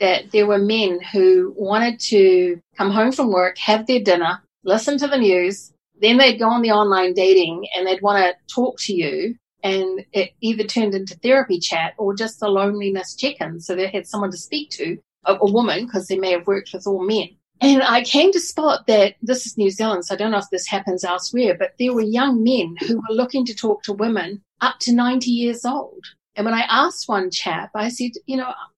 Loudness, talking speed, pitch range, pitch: -19 LUFS, 225 wpm, 190-240 Hz, 210 Hz